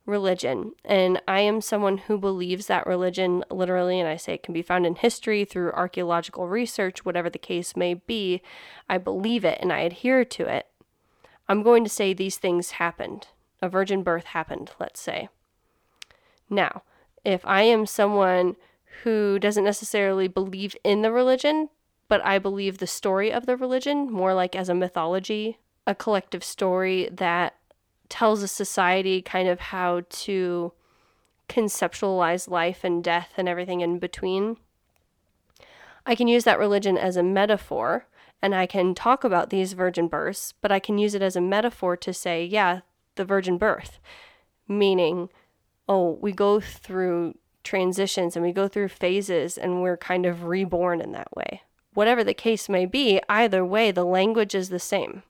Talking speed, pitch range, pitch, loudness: 165 wpm, 180-205 Hz, 190 Hz, -24 LUFS